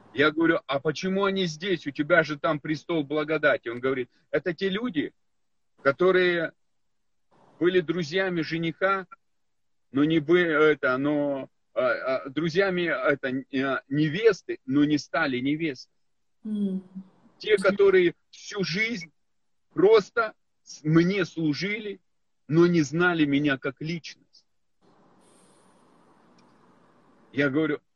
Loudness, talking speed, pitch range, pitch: -25 LUFS, 105 wpm, 150-195 Hz, 165 Hz